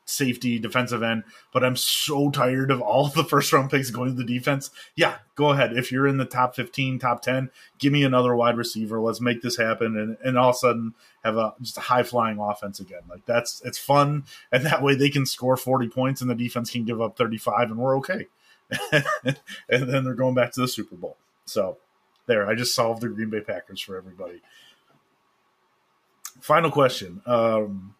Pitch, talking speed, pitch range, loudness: 125 Hz, 210 wpm, 115-130 Hz, -23 LUFS